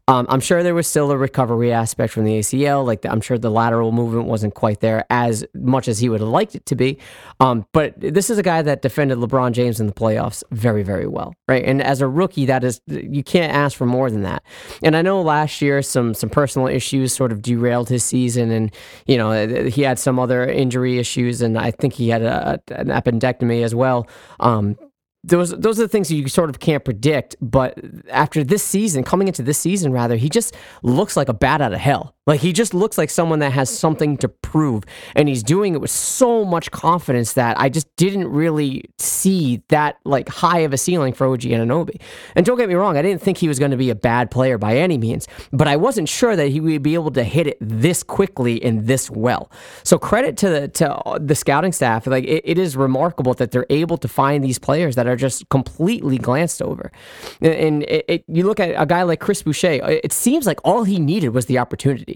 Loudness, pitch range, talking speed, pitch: -18 LUFS, 120-160 Hz, 235 wpm, 135 Hz